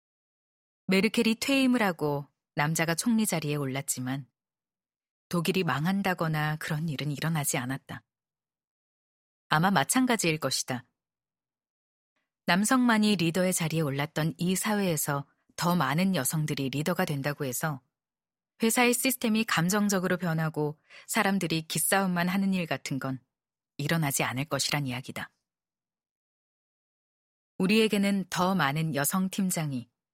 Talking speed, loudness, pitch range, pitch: 275 characters per minute, -28 LUFS, 145-190 Hz, 165 Hz